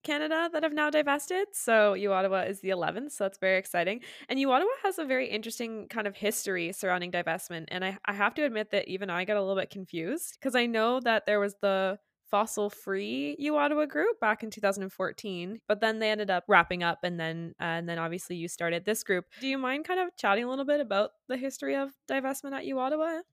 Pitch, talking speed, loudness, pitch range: 210 Hz, 240 wpm, -30 LUFS, 190-270 Hz